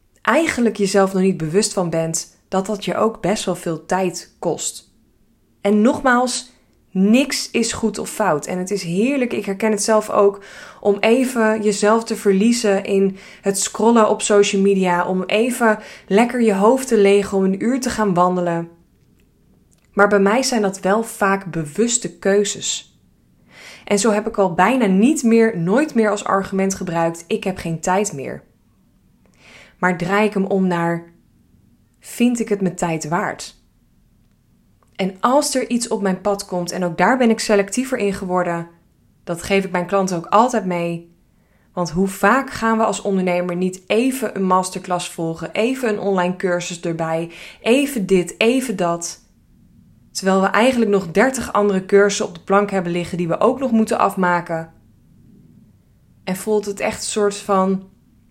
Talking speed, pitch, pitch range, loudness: 170 wpm, 200 Hz, 180-220 Hz, -18 LUFS